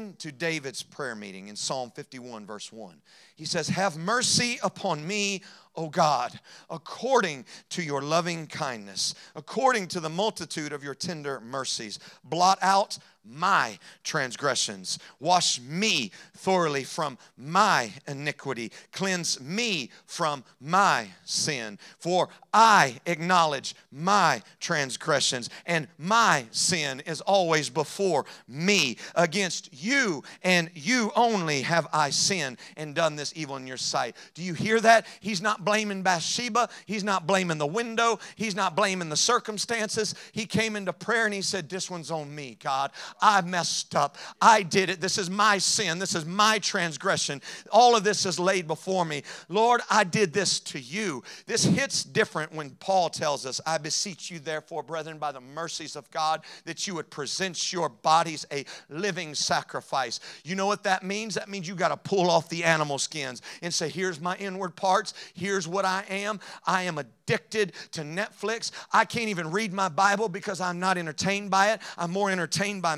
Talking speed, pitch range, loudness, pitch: 165 wpm, 155-200 Hz, -26 LUFS, 180 Hz